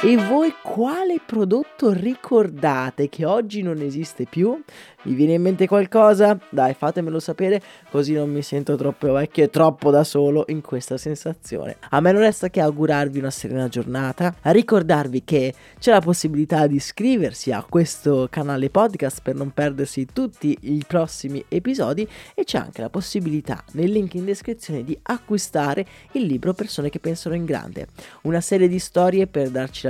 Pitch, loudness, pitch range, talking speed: 160 Hz, -21 LUFS, 145-200 Hz, 170 wpm